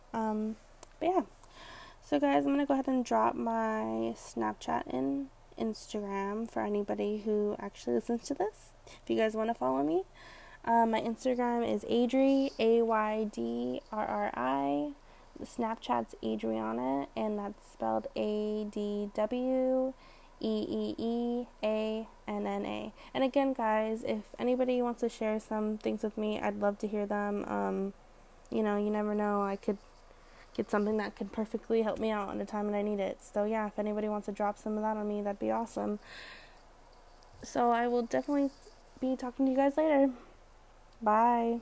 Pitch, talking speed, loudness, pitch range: 215 Hz, 175 wpm, -33 LUFS, 200-235 Hz